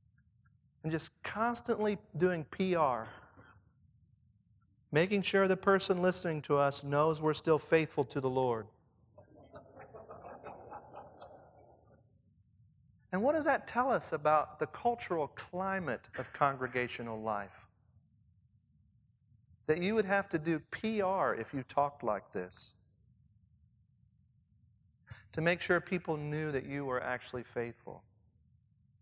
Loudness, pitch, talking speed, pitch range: -34 LUFS, 135 Hz, 110 wpm, 115-170 Hz